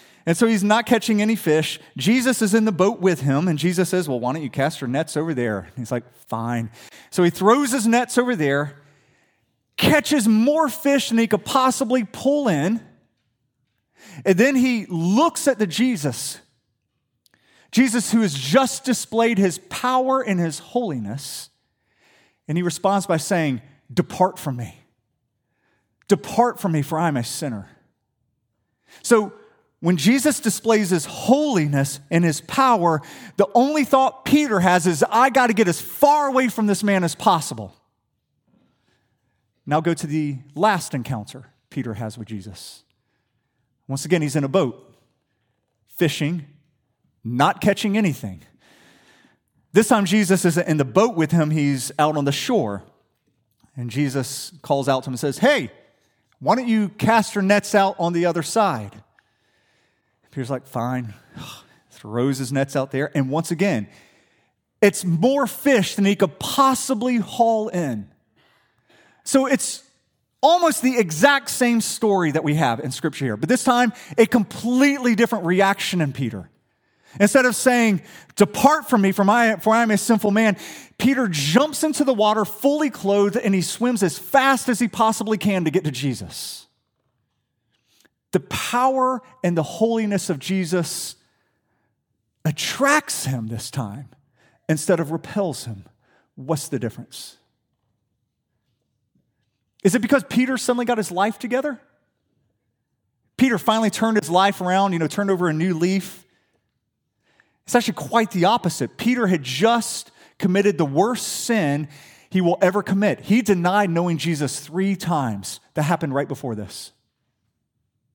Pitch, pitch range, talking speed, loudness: 175 Hz, 135-225 Hz, 155 wpm, -20 LUFS